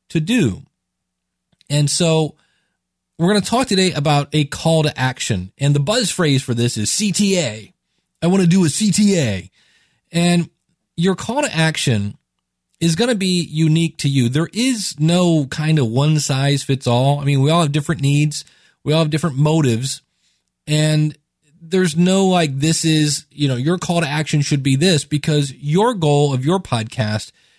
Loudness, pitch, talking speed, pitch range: -17 LUFS, 155 Hz, 180 wpm, 135-170 Hz